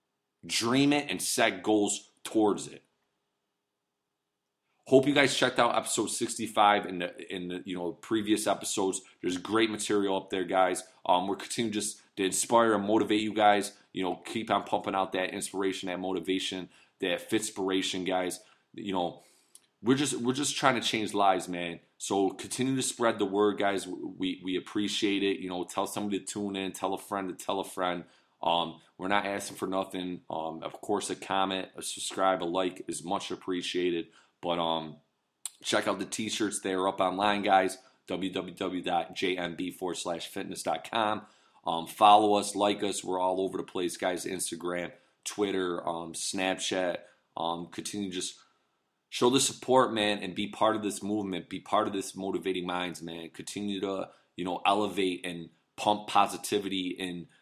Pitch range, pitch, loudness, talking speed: 90-105 Hz, 95 Hz, -30 LUFS, 170 wpm